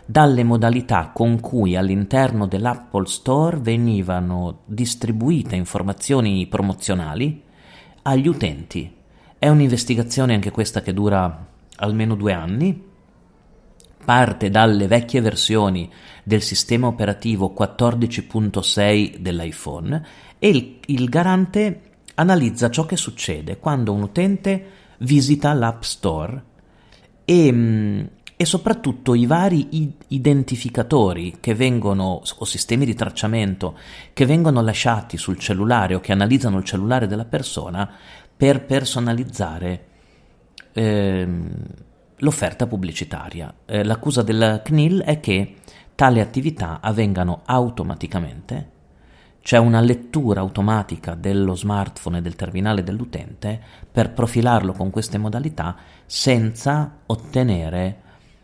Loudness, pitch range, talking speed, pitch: -20 LUFS, 95-130 Hz, 105 wpm, 110 Hz